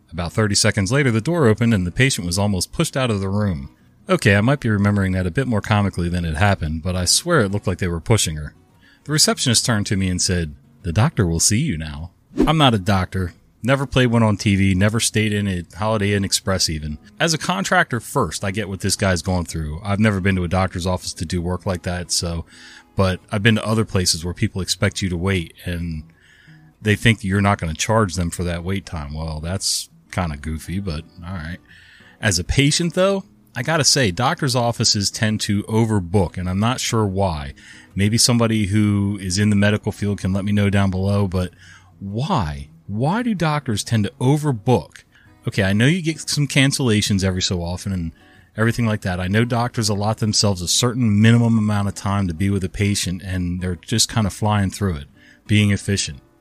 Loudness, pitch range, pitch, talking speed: -19 LUFS, 90-115 Hz, 100 Hz, 220 wpm